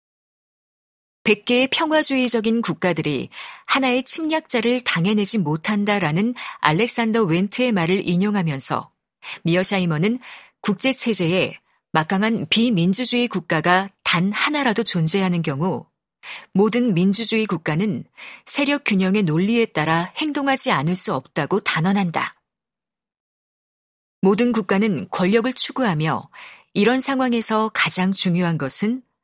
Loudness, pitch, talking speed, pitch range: -19 LUFS, 205 Hz, 275 characters per minute, 180-240 Hz